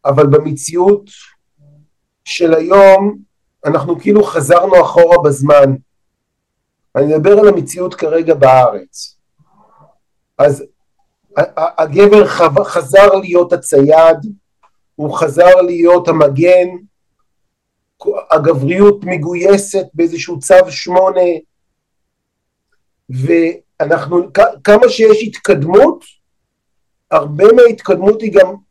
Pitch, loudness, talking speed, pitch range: 175 Hz, -10 LUFS, 75 wpm, 160-195 Hz